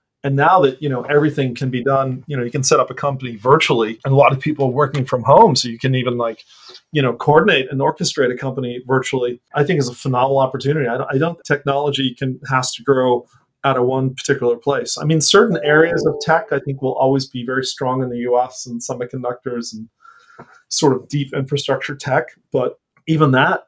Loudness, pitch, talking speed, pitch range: -17 LUFS, 135 Hz, 220 wpm, 125-145 Hz